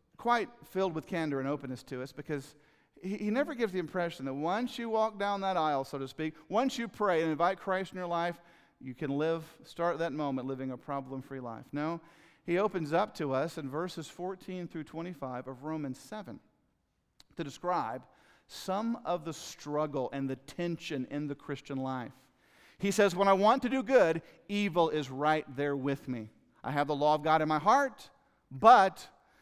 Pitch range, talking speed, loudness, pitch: 140-185 Hz, 195 wpm, -32 LUFS, 160 Hz